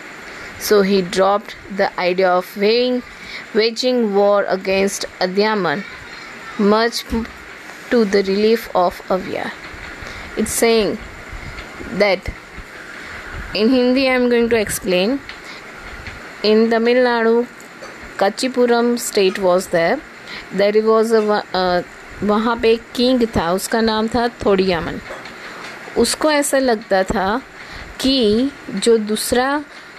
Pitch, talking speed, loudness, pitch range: 220 Hz, 100 wpm, -17 LUFS, 200-240 Hz